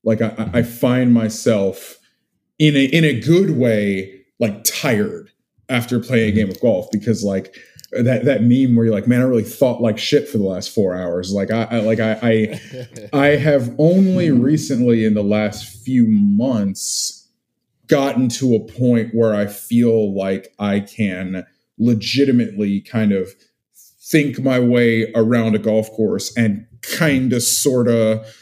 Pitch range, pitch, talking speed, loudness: 105-130 Hz, 115 Hz, 165 wpm, -17 LUFS